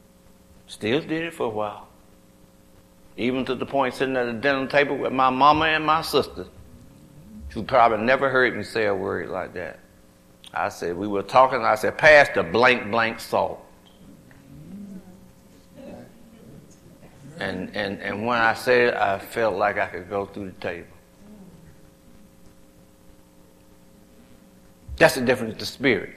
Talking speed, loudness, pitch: 145 wpm, -22 LUFS, 105 Hz